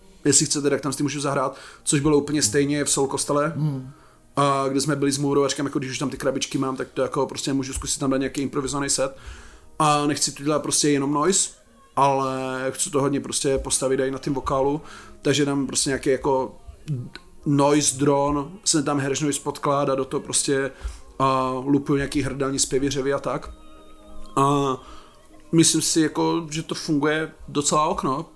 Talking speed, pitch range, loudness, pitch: 180 wpm, 135-145 Hz, -22 LUFS, 140 Hz